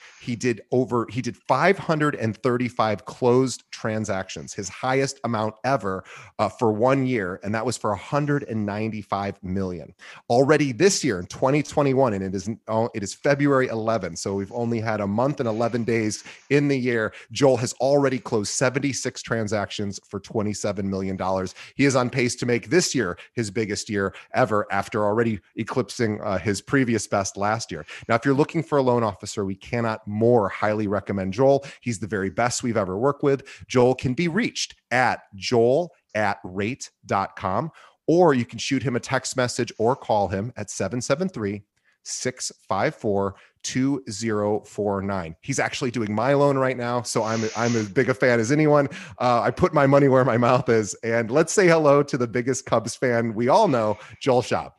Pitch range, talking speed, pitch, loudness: 105-130 Hz, 175 wpm, 120 Hz, -23 LUFS